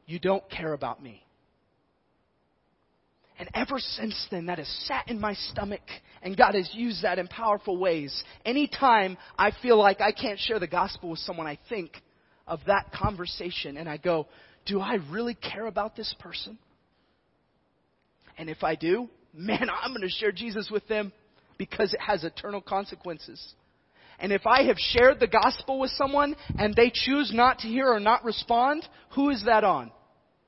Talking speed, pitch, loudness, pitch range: 175 wpm, 210 Hz, -26 LUFS, 180-240 Hz